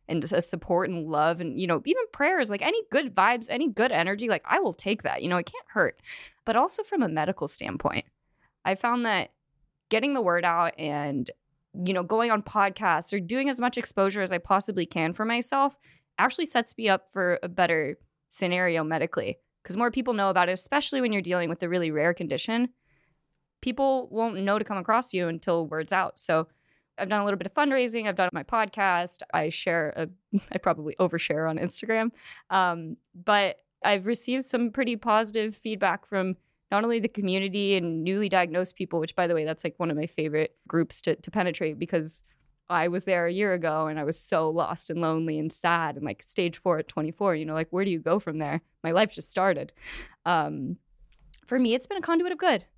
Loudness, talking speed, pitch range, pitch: -27 LUFS, 210 wpm, 165-225 Hz, 185 Hz